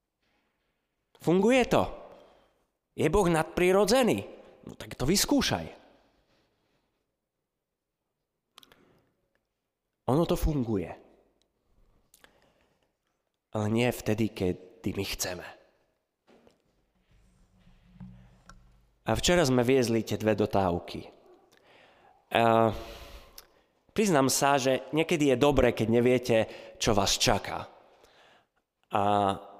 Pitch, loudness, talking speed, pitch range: 115 Hz, -27 LUFS, 75 wpm, 100-145 Hz